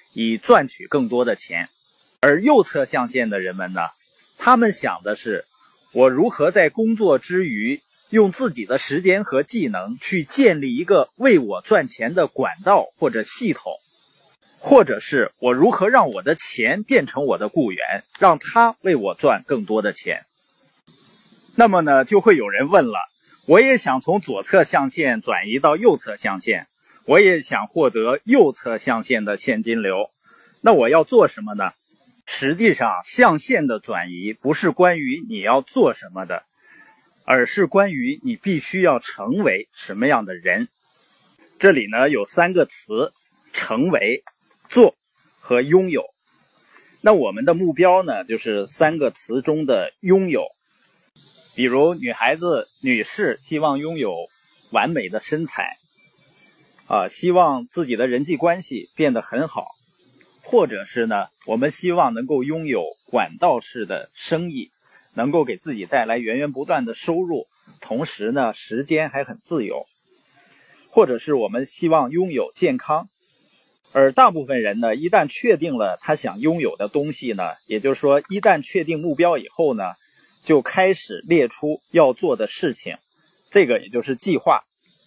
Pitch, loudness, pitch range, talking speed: 175 Hz, -19 LUFS, 140-225 Hz, 225 characters per minute